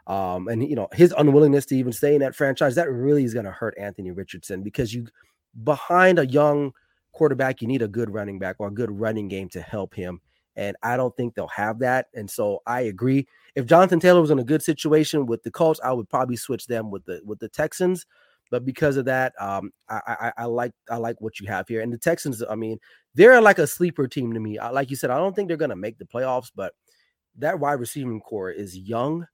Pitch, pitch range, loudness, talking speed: 125 Hz, 110-150 Hz, -22 LUFS, 240 wpm